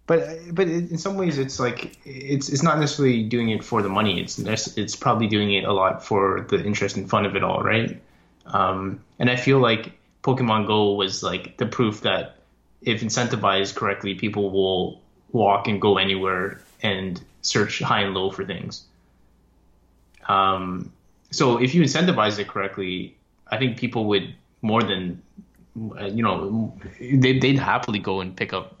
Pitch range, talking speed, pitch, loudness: 95-125 Hz, 170 wpm, 105 Hz, -22 LUFS